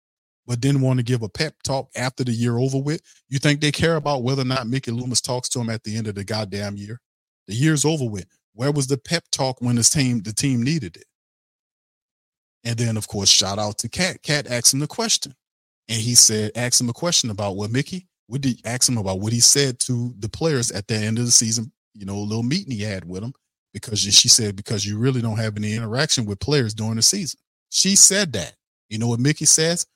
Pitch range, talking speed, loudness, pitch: 110-140 Hz, 240 wpm, -19 LUFS, 120 Hz